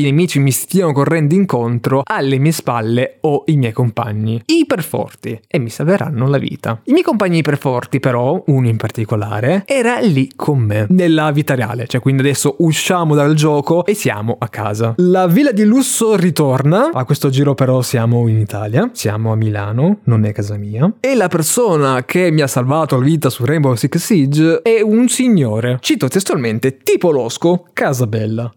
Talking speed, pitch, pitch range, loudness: 175 wpm, 140 Hz, 120-170 Hz, -14 LUFS